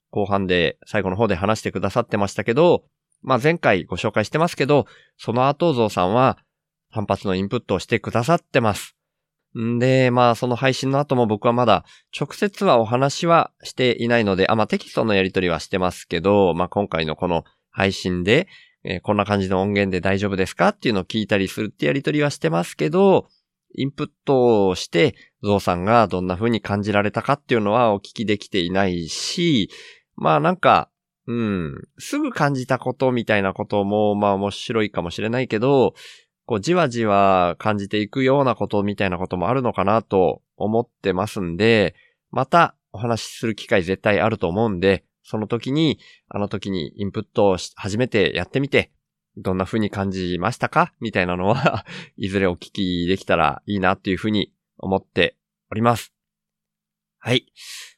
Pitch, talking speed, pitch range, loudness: 105 Hz, 365 characters per minute, 95-125 Hz, -20 LUFS